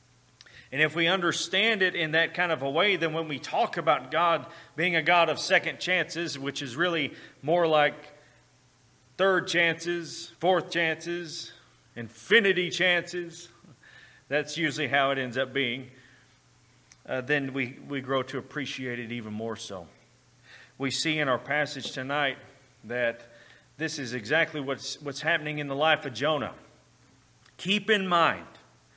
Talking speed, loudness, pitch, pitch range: 150 wpm, -27 LUFS, 150 Hz, 130-170 Hz